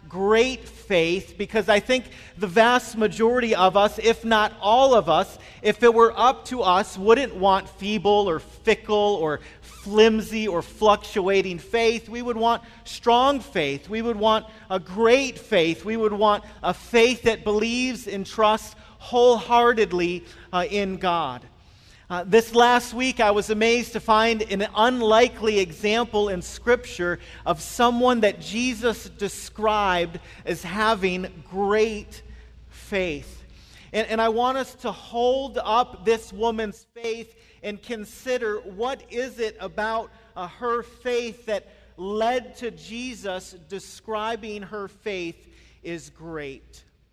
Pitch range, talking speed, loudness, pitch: 195-230 Hz, 135 wpm, -22 LUFS, 215 Hz